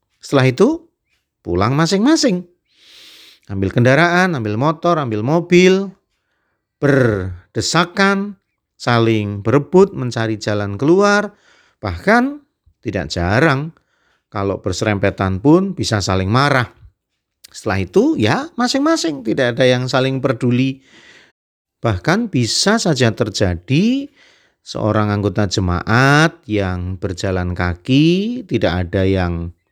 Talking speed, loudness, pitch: 95 wpm, -16 LUFS, 130 Hz